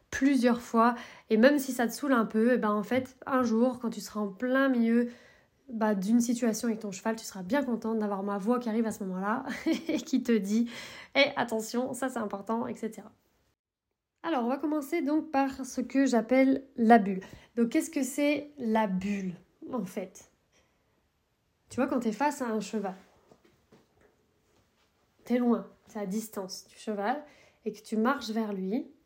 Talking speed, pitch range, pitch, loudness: 190 wpm, 215-265 Hz, 235 Hz, -29 LUFS